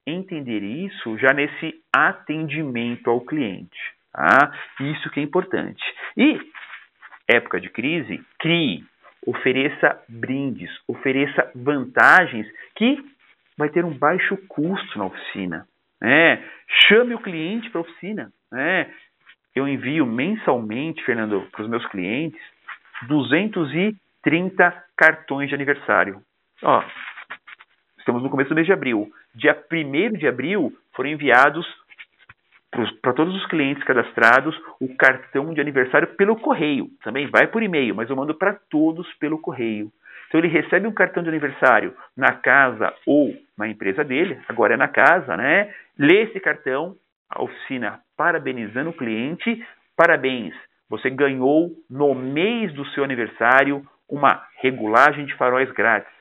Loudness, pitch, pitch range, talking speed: -20 LUFS, 150 Hz, 135-180 Hz, 130 wpm